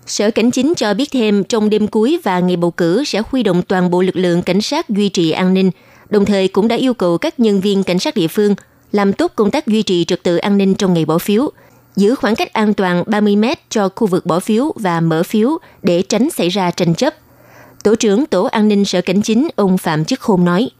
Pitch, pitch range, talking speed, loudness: 200 Hz, 180-220 Hz, 250 wpm, -15 LUFS